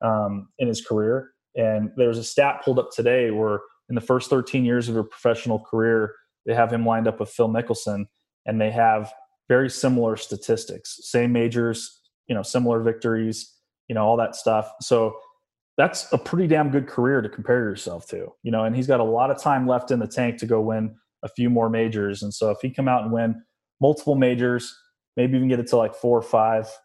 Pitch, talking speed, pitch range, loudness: 115 Hz, 215 wpm, 110-125 Hz, -23 LUFS